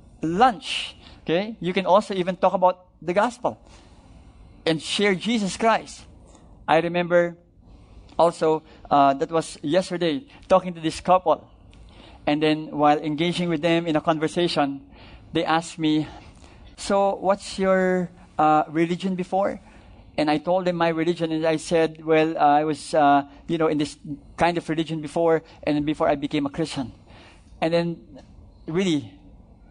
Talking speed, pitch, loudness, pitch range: 150 wpm, 160 Hz, -23 LUFS, 140-175 Hz